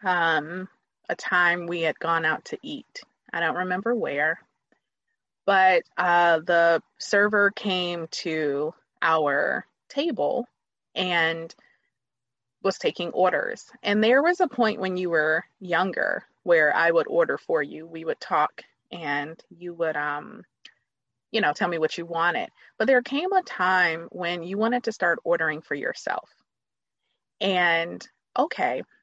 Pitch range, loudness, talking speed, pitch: 160-205 Hz, -24 LUFS, 145 wpm, 175 Hz